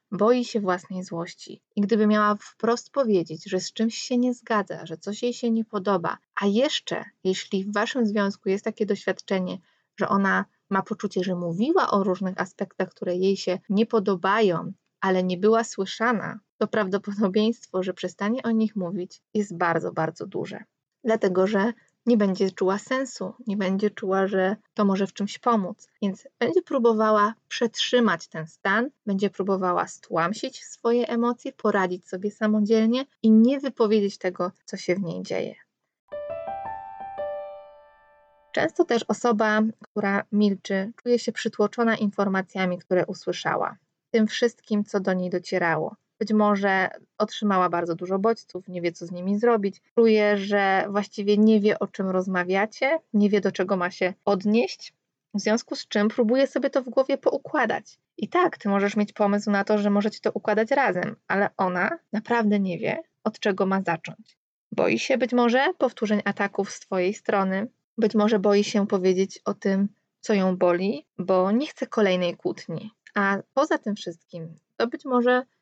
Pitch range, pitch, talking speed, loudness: 190-230 Hz, 205 Hz, 160 wpm, -25 LUFS